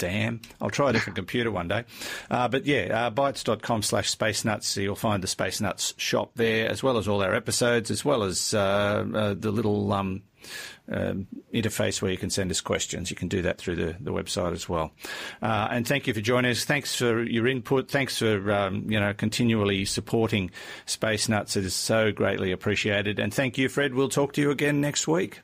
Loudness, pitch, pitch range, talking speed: -26 LUFS, 110 Hz, 100-120 Hz, 210 wpm